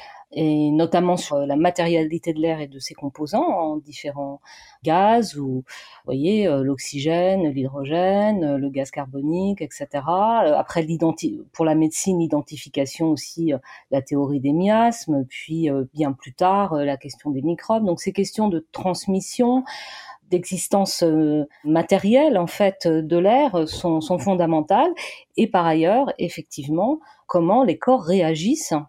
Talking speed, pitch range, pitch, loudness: 130 wpm, 150-195 Hz, 165 Hz, -21 LUFS